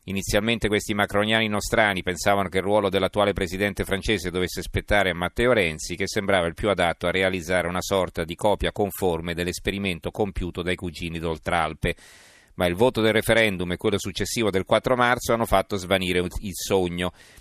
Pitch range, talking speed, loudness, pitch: 90-105 Hz, 170 wpm, -24 LUFS, 95 Hz